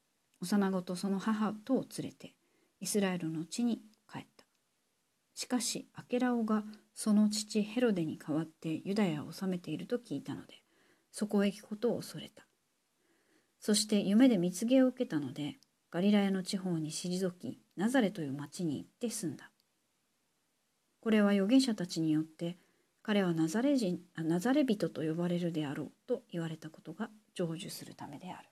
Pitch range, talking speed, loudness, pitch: 170-220 Hz, 325 characters per minute, -34 LUFS, 195 Hz